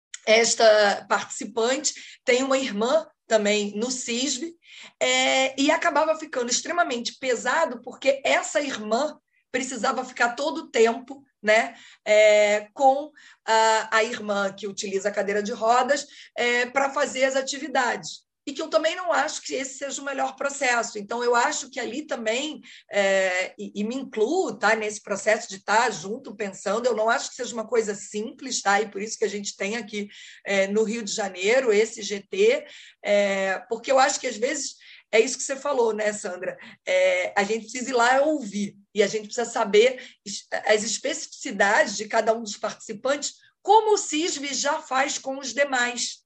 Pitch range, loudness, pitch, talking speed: 215-280 Hz, -24 LUFS, 245 Hz, 175 wpm